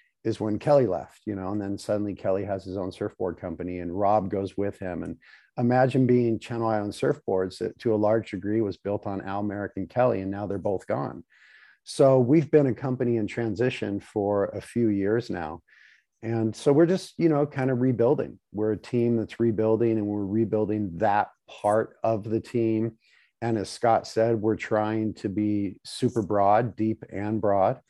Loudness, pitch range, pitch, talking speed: -26 LUFS, 100-115 Hz, 110 Hz, 195 wpm